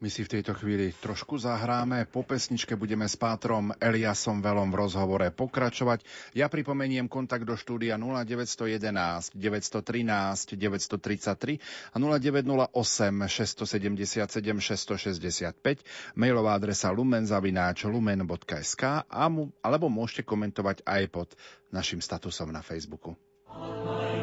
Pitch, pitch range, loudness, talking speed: 110 Hz, 100-120 Hz, -30 LUFS, 105 wpm